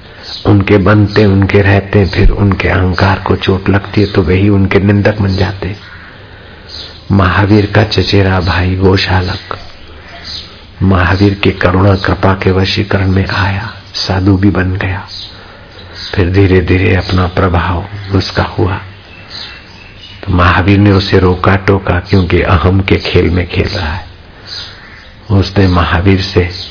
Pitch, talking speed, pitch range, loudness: 95 Hz, 130 wpm, 90-100 Hz, -10 LUFS